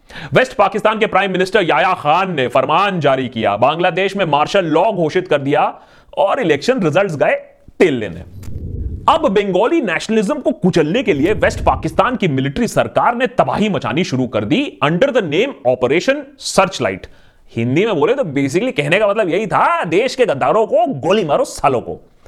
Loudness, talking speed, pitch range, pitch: -15 LUFS, 175 wpm, 160-255 Hz, 190 Hz